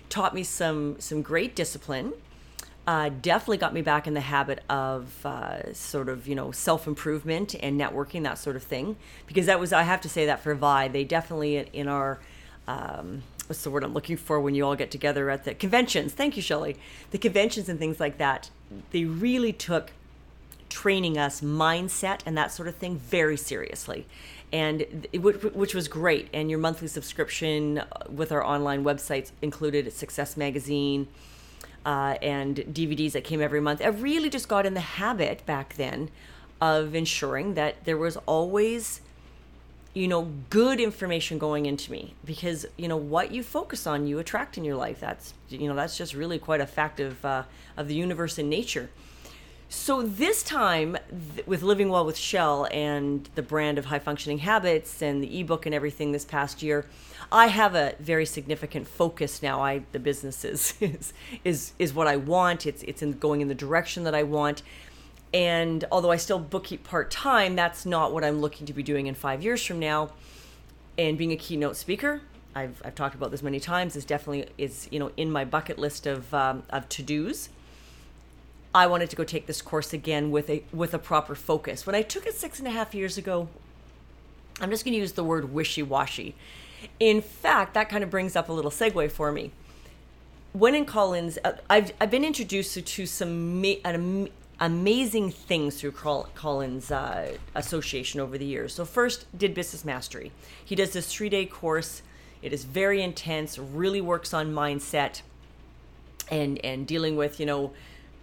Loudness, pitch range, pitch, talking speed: -27 LUFS, 140-180 Hz, 155 Hz, 190 wpm